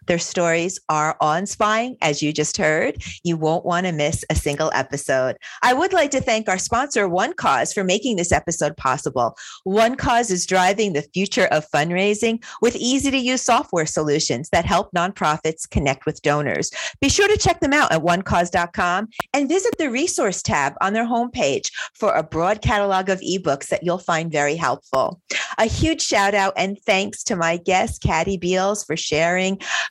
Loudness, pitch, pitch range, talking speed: -20 LUFS, 185 Hz, 160-225 Hz, 185 wpm